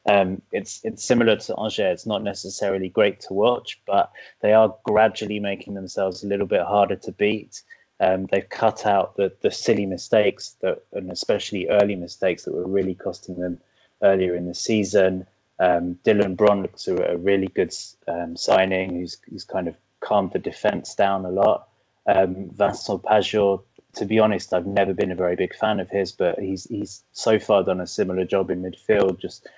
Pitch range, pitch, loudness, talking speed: 95-105 Hz, 100 Hz, -22 LUFS, 185 wpm